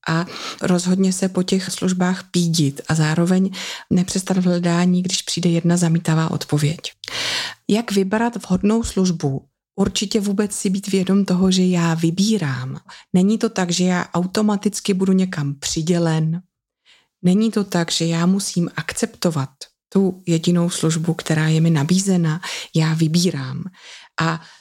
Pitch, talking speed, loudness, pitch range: 180 Hz, 135 wpm, -19 LUFS, 165-195 Hz